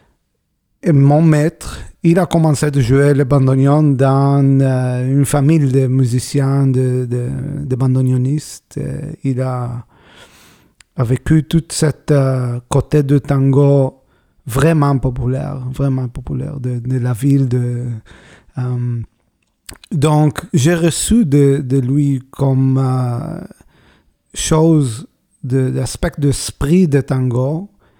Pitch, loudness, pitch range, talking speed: 135 Hz, -15 LUFS, 130-145 Hz, 115 wpm